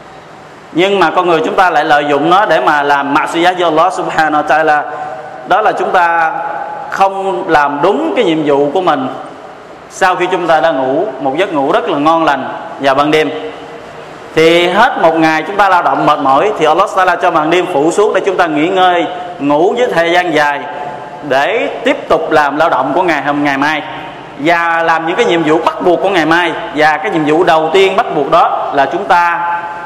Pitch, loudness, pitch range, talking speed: 160 Hz, -11 LUFS, 150-180 Hz, 215 wpm